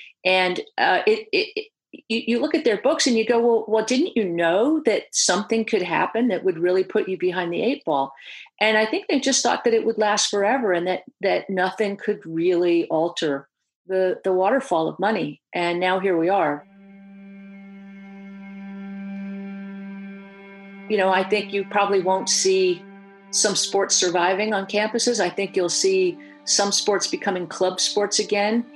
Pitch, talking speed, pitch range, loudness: 195 Hz, 175 wpm, 190-225 Hz, -21 LUFS